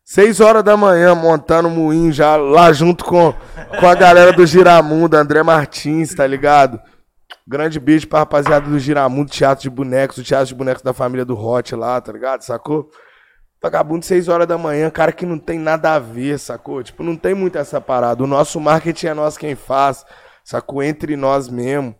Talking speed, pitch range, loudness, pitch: 195 wpm, 135-165 Hz, -13 LUFS, 150 Hz